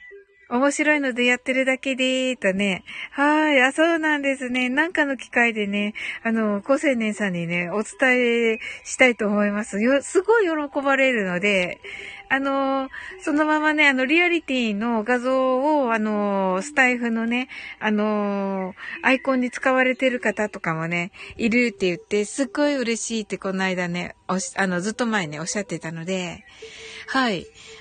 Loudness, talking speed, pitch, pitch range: -22 LUFS, 315 characters per minute, 245 Hz, 205-275 Hz